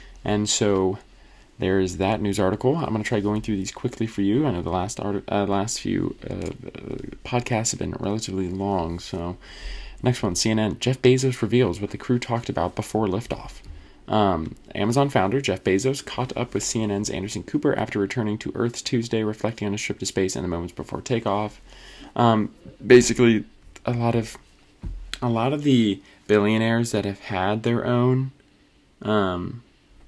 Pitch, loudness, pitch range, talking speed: 105 Hz, -24 LUFS, 95-120 Hz, 175 wpm